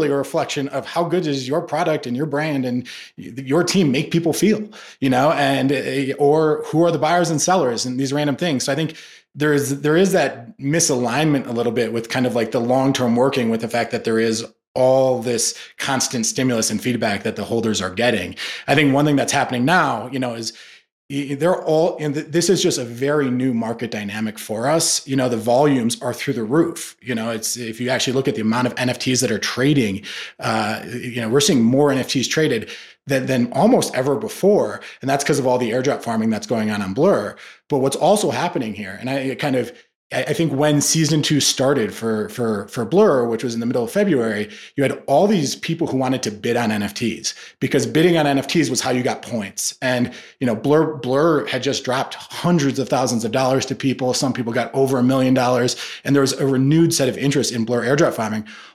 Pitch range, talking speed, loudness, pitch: 120-150 Hz, 225 wpm, -19 LUFS, 135 Hz